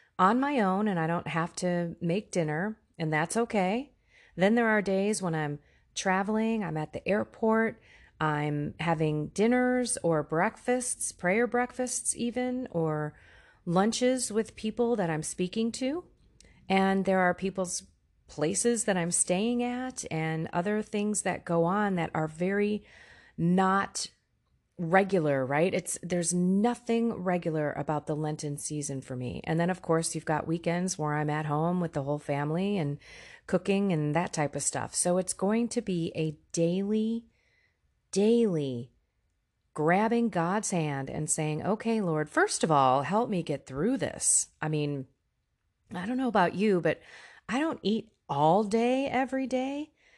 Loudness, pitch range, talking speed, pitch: -29 LUFS, 155-220 Hz, 155 wpm, 180 Hz